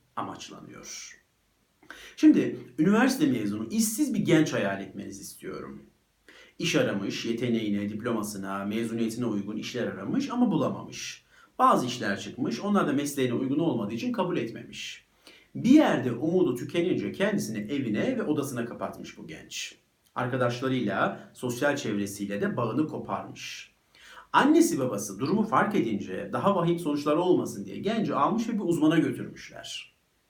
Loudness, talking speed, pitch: -27 LUFS, 125 wpm, 130 Hz